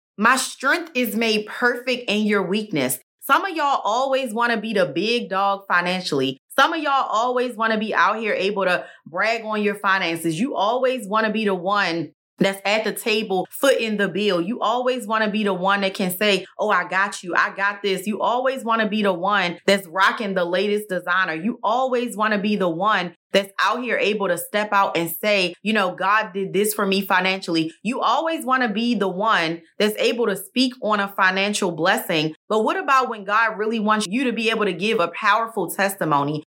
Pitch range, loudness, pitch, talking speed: 190-230 Hz, -21 LUFS, 205 Hz, 205 wpm